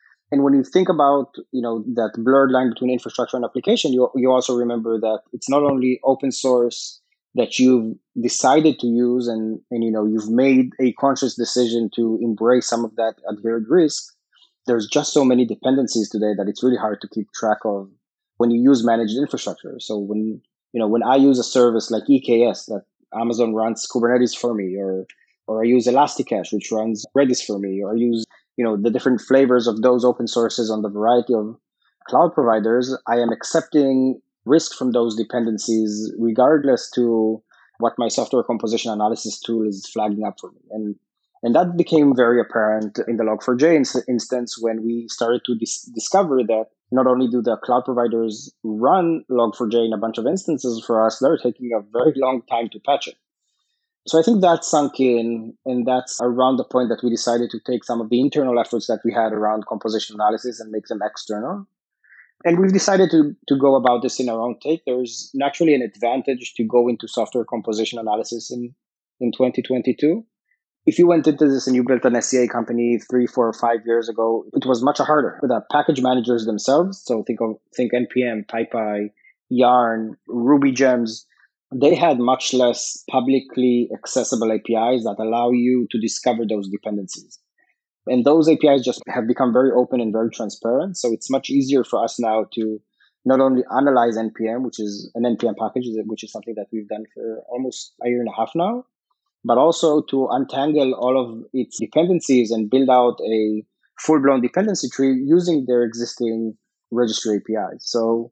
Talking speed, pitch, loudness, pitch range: 185 wpm, 120 Hz, -19 LUFS, 115-130 Hz